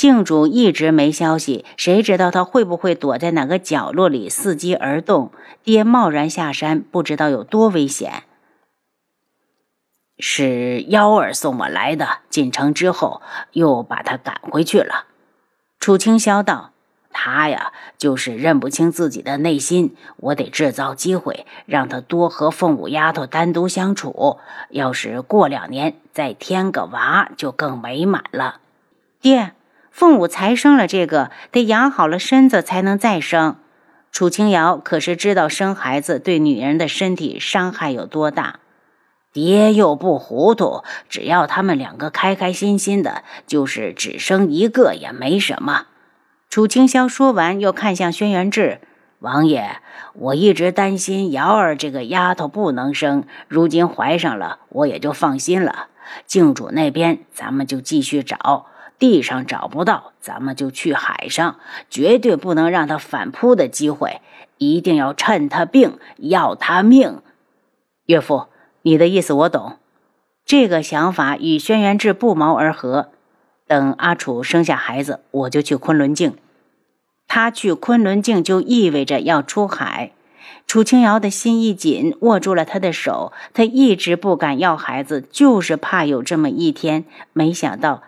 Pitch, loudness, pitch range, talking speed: 180 Hz, -17 LUFS, 155-220 Hz, 220 characters per minute